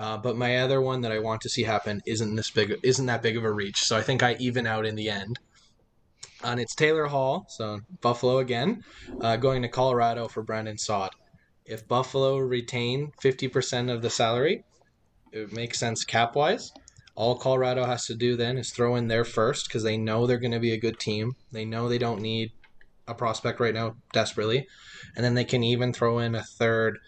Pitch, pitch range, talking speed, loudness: 120 Hz, 110-125 Hz, 215 wpm, -27 LUFS